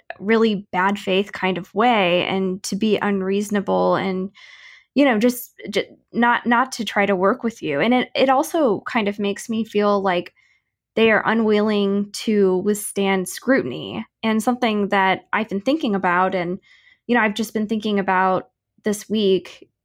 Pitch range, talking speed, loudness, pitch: 190-225 Hz, 170 wpm, -20 LUFS, 205 Hz